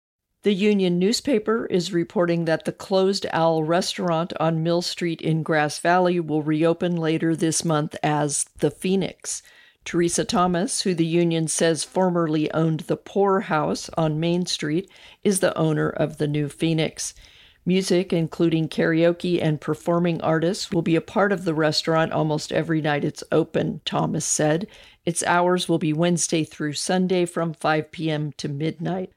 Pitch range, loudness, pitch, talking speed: 155-180 Hz, -23 LUFS, 165 Hz, 160 wpm